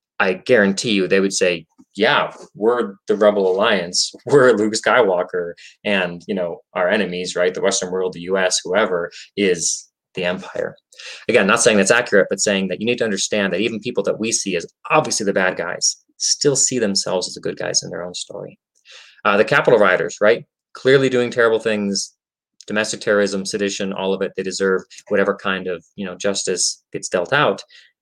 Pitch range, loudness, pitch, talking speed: 95-115 Hz, -18 LUFS, 100 Hz, 190 wpm